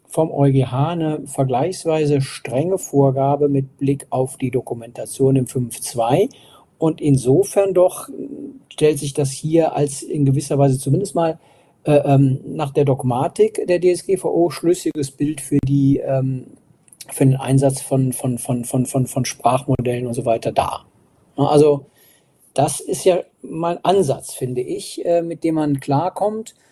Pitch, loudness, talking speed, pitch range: 140 Hz, -19 LUFS, 150 wpm, 135-160 Hz